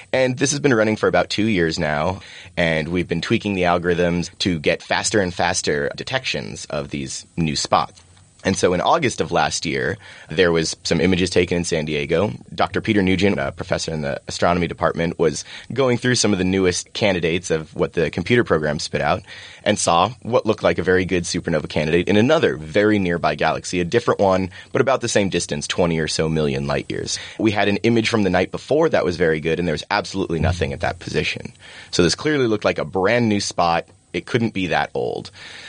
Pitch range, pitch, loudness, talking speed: 80-105 Hz, 90 Hz, -20 LUFS, 215 wpm